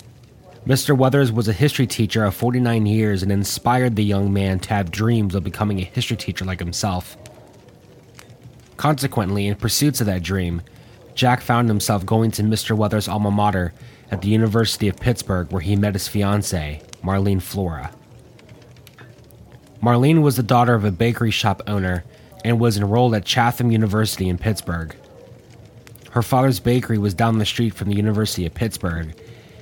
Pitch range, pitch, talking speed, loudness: 100-120 Hz, 110 Hz, 160 wpm, -20 LUFS